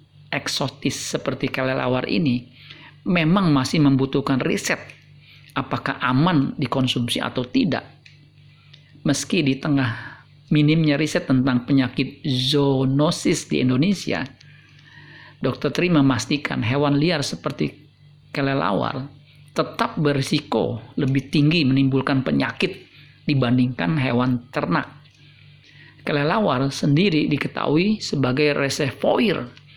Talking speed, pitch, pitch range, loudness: 90 wpm, 140 Hz, 135-145 Hz, -21 LUFS